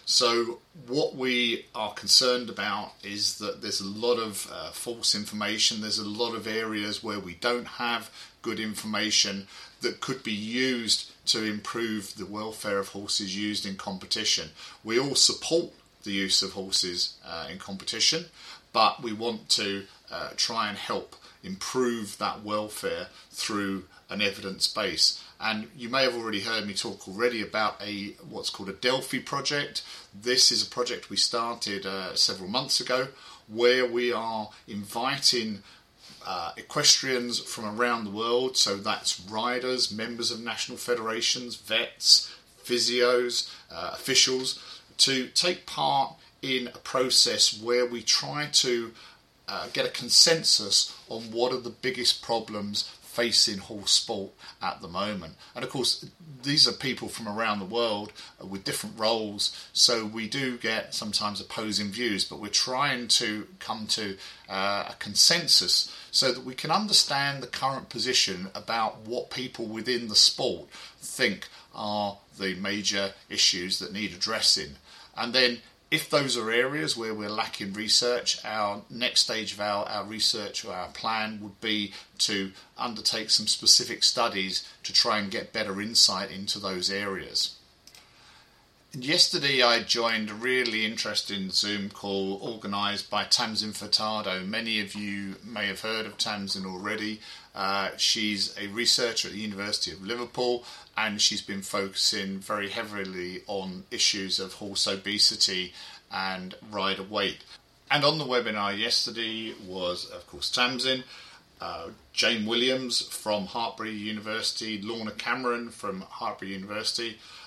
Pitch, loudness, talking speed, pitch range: 110 Hz, -26 LUFS, 150 wpm, 100-120 Hz